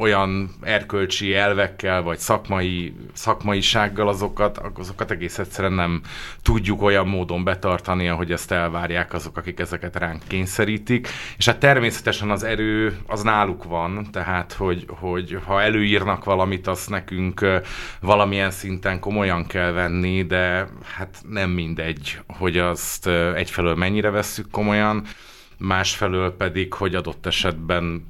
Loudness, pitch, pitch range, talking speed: -22 LUFS, 95 Hz, 90-105 Hz, 125 wpm